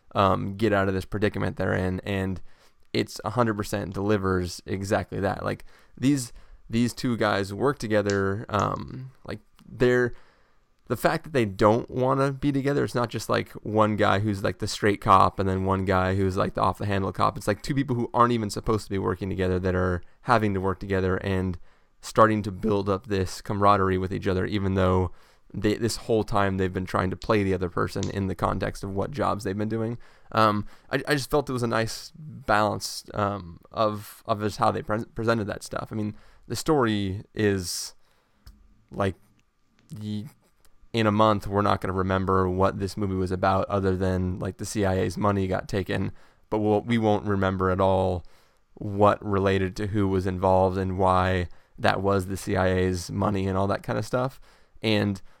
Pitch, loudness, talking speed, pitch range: 100 Hz, -26 LUFS, 195 wpm, 95-110 Hz